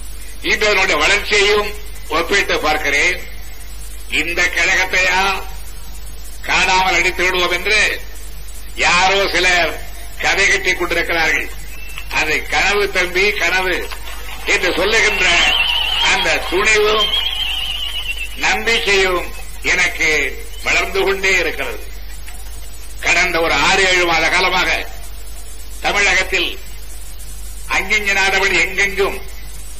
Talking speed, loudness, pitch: 70 wpm, -14 LUFS, 175 Hz